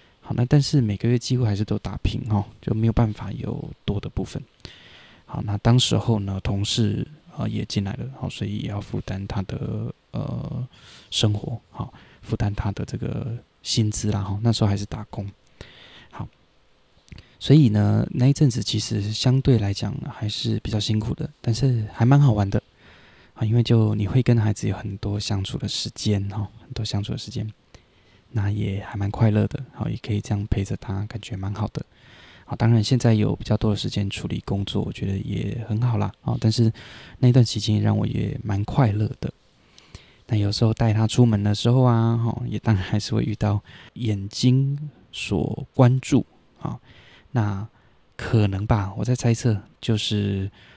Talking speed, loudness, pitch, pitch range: 270 characters per minute, -23 LUFS, 110 Hz, 105-120 Hz